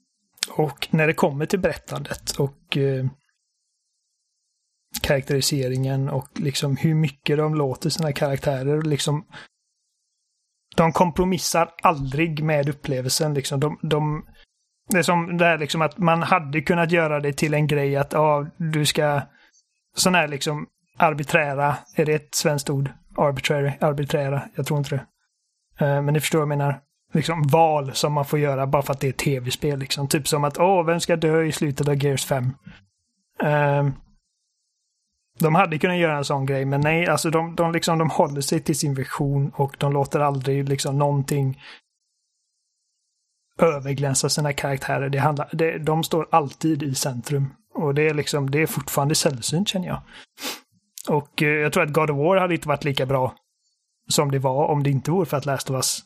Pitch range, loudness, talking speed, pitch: 140-160 Hz, -22 LUFS, 175 wpm, 150 Hz